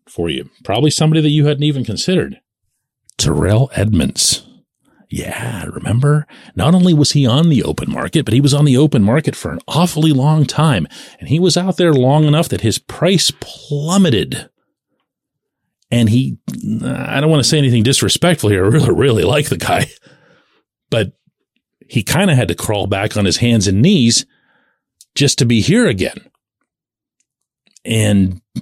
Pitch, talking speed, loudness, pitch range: 140 Hz, 165 wpm, -14 LUFS, 115-155 Hz